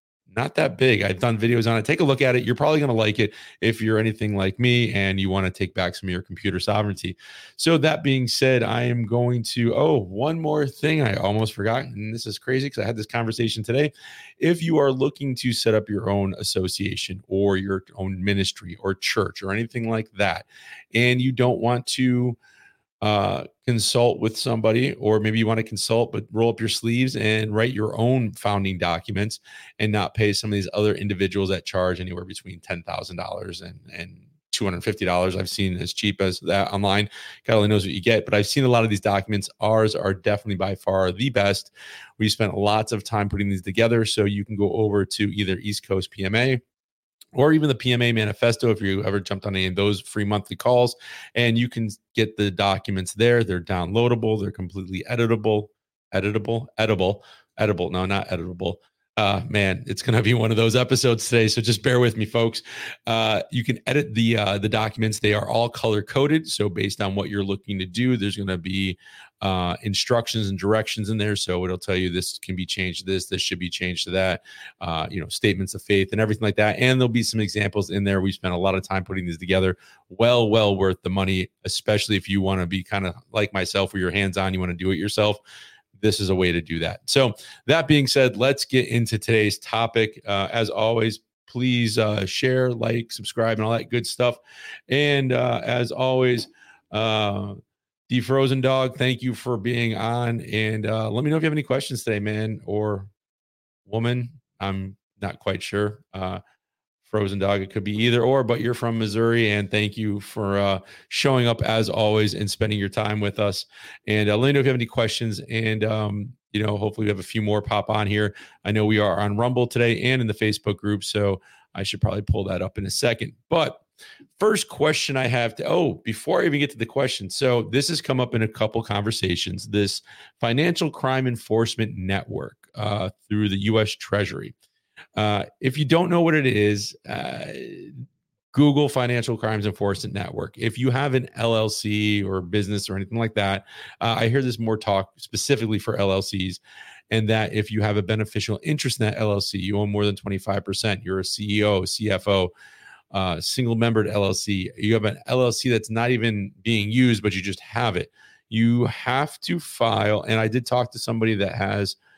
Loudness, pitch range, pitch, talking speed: -23 LUFS, 100-120 Hz, 110 Hz, 205 wpm